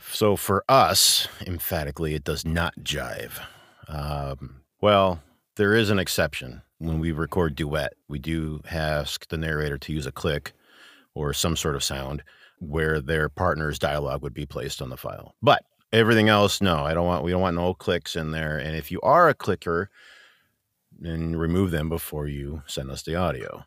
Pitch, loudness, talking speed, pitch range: 80 Hz, -24 LUFS, 180 wpm, 75-90 Hz